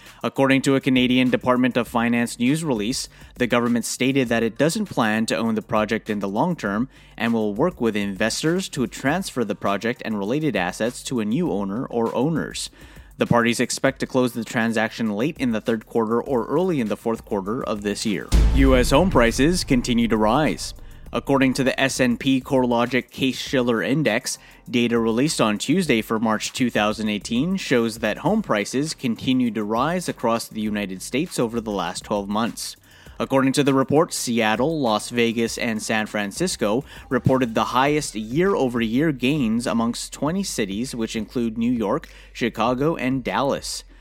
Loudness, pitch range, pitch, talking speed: -22 LUFS, 110-135 Hz, 120 Hz, 170 wpm